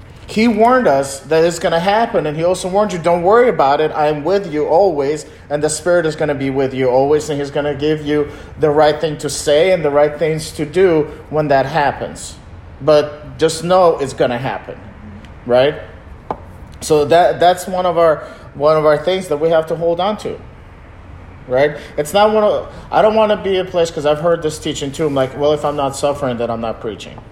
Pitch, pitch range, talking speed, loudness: 150 Hz, 145-175 Hz, 235 wpm, -15 LUFS